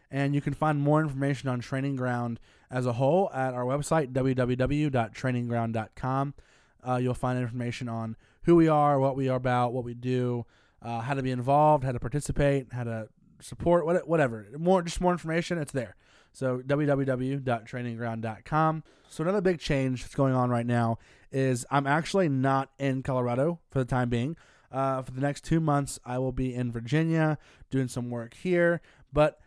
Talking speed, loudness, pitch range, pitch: 175 wpm, -28 LUFS, 125-150 Hz, 135 Hz